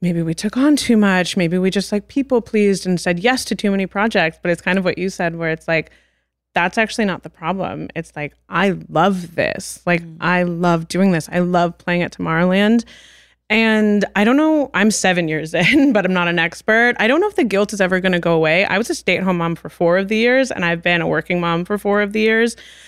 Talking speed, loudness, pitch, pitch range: 255 wpm, -17 LUFS, 185 Hz, 175-215 Hz